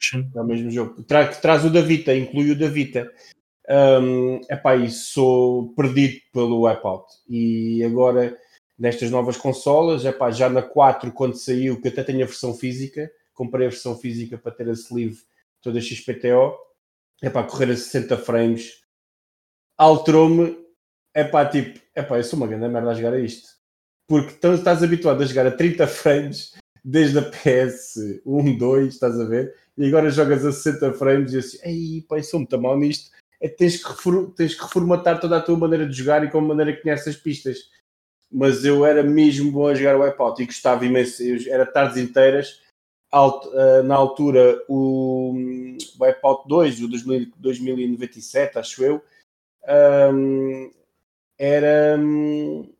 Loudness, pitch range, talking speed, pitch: -19 LUFS, 125-150 Hz, 170 wpm, 135 Hz